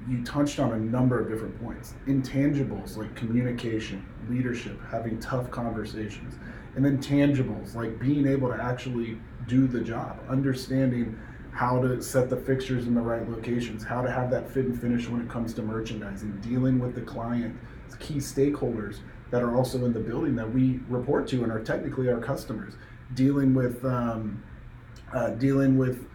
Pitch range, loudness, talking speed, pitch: 115-130 Hz, -28 LUFS, 170 wpm, 120 Hz